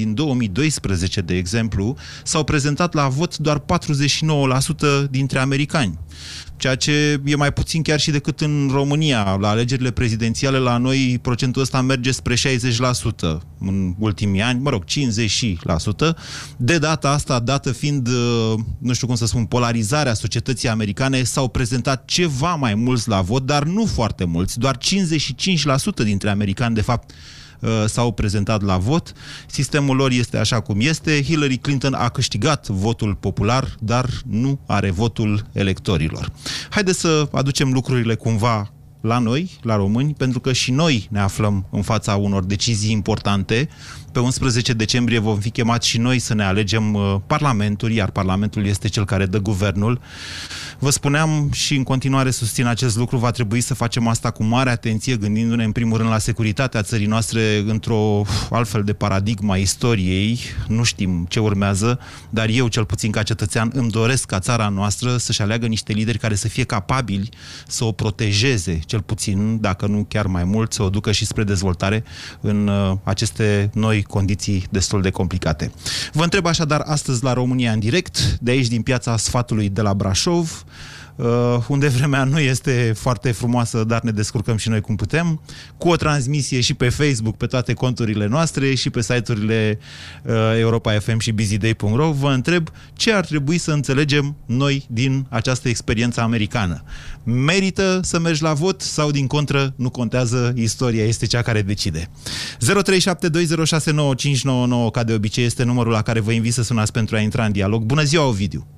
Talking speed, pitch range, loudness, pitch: 165 wpm, 110-135 Hz, -19 LUFS, 120 Hz